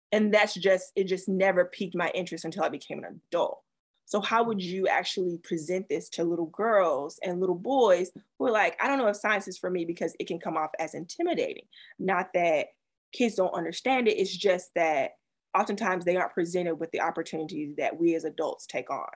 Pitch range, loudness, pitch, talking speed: 170-205 Hz, -28 LUFS, 185 Hz, 210 wpm